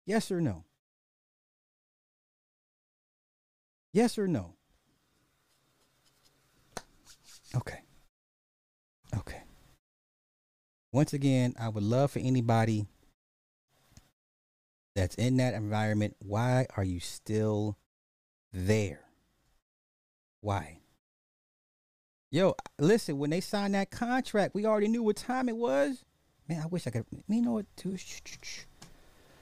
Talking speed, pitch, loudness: 105 wpm, 120 Hz, -31 LUFS